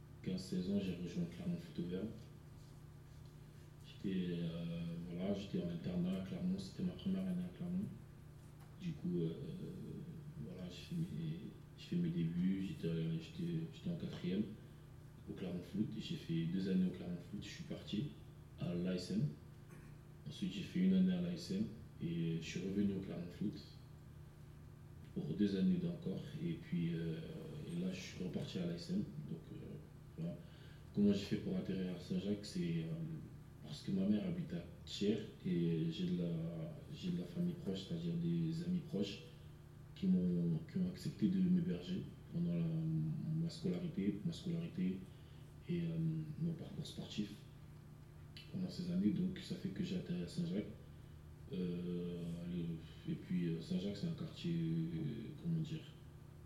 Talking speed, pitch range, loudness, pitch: 155 wpm, 140-175 Hz, -42 LUFS, 165 Hz